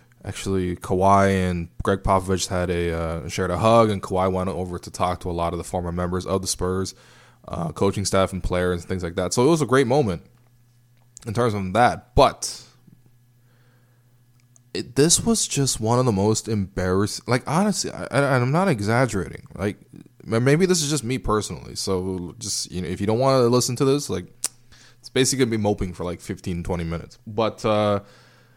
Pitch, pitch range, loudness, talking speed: 105 Hz, 95-120 Hz, -22 LUFS, 200 wpm